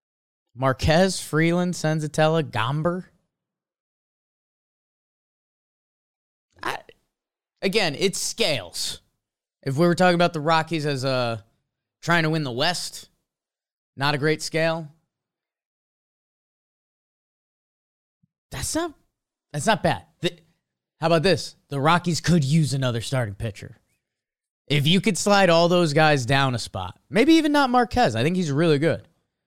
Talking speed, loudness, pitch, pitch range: 125 wpm, -22 LUFS, 160 Hz, 135-175 Hz